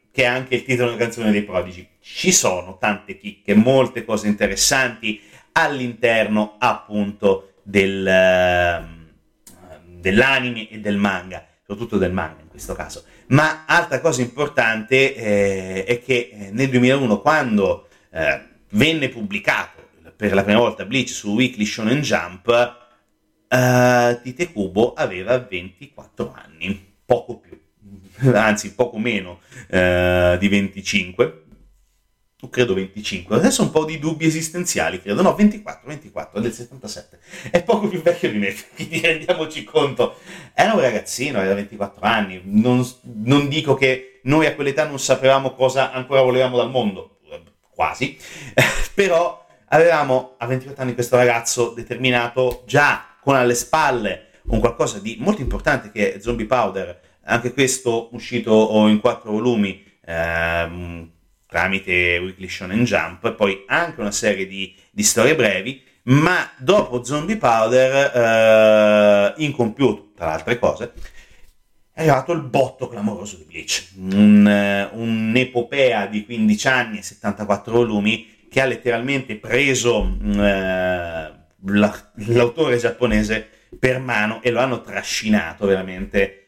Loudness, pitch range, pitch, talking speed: -19 LUFS, 100-130 Hz, 115 Hz, 130 wpm